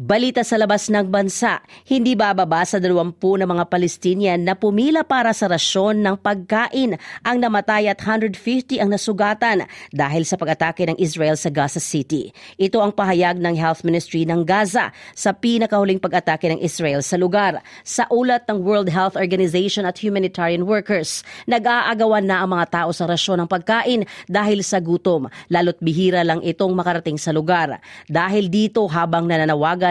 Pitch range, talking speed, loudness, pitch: 170-215 Hz, 160 wpm, -19 LUFS, 190 Hz